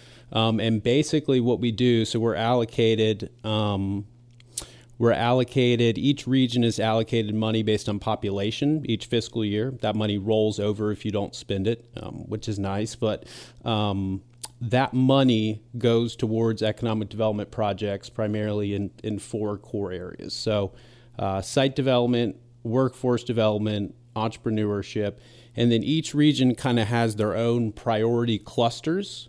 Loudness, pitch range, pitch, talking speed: -25 LUFS, 105-120 Hz, 115 Hz, 140 wpm